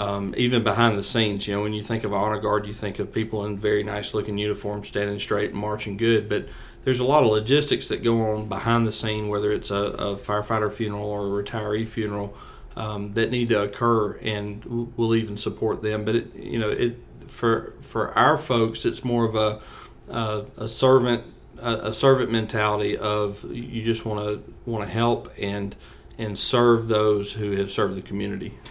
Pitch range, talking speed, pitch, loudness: 105-115 Hz, 200 wpm, 105 Hz, -24 LUFS